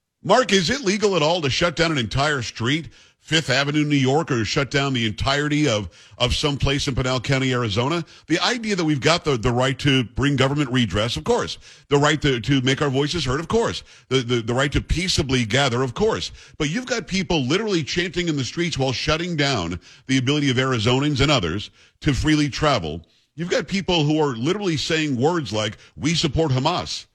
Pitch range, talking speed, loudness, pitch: 125-160 Hz, 210 wpm, -21 LUFS, 140 Hz